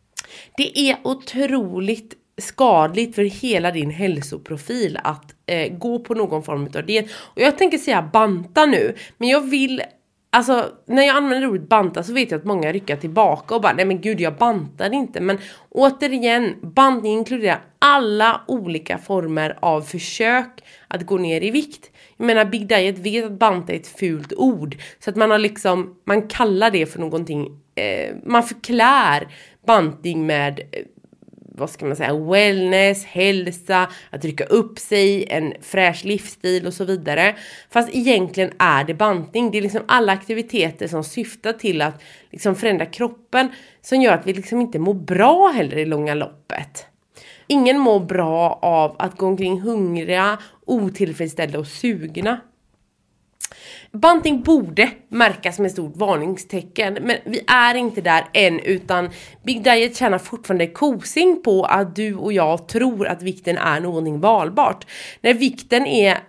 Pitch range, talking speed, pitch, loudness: 175-240 Hz, 160 wpm, 205 Hz, -18 LUFS